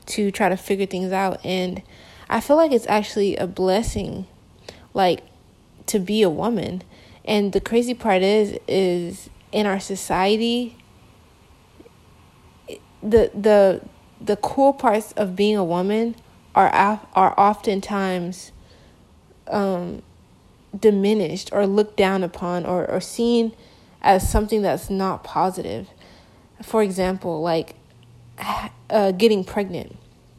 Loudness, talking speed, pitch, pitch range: -21 LUFS, 120 wpm, 200 Hz, 185-215 Hz